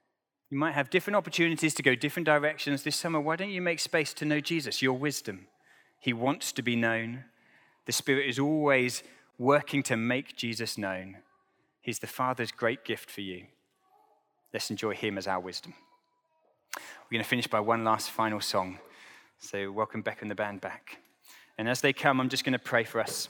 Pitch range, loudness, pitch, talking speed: 115-150 Hz, -30 LUFS, 130 Hz, 195 wpm